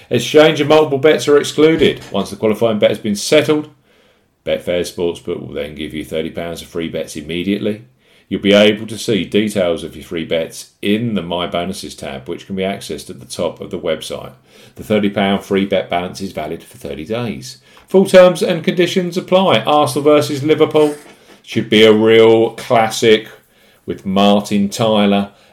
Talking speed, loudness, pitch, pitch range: 175 wpm, -15 LUFS, 105 Hz, 95-150 Hz